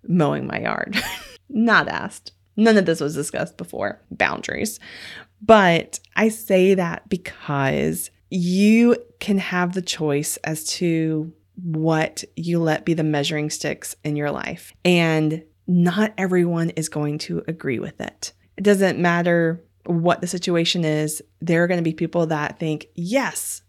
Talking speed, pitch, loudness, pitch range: 150 wpm, 170 Hz, -21 LUFS, 155-185 Hz